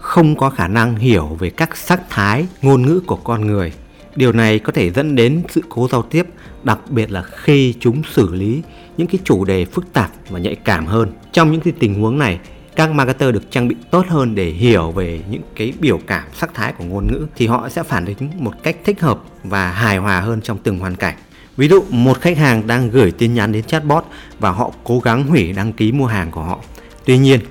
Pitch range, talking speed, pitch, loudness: 105-155 Hz, 235 wpm, 120 Hz, -16 LUFS